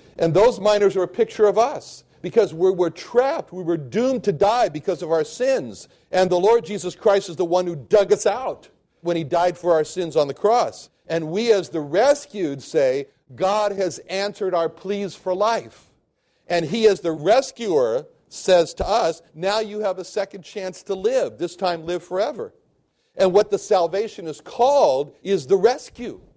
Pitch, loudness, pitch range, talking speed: 195 Hz, -21 LUFS, 175-215 Hz, 190 wpm